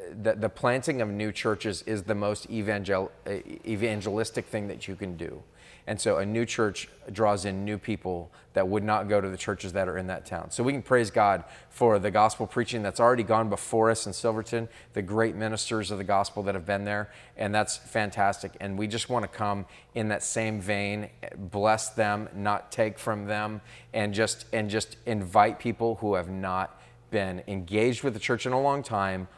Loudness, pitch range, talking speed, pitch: -28 LUFS, 100-115 Hz, 200 wpm, 105 Hz